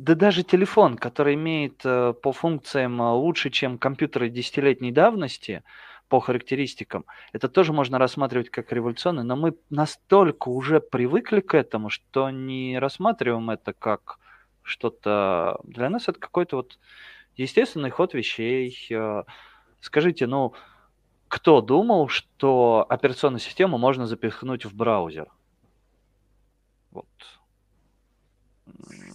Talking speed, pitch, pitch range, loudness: 110 wpm, 130 Hz, 120-155 Hz, -23 LUFS